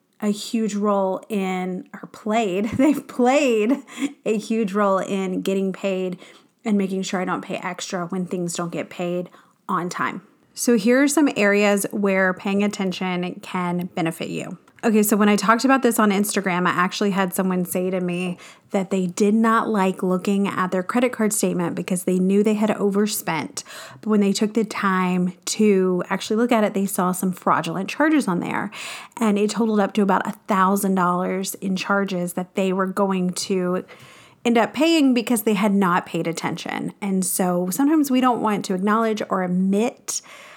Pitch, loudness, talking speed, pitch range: 200 Hz, -21 LUFS, 185 wpm, 185-220 Hz